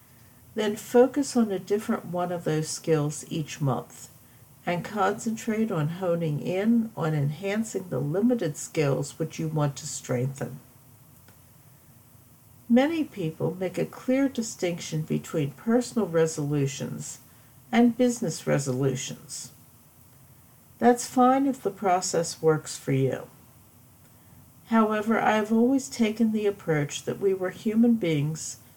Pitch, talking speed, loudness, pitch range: 165 Hz, 120 wpm, -26 LUFS, 140-220 Hz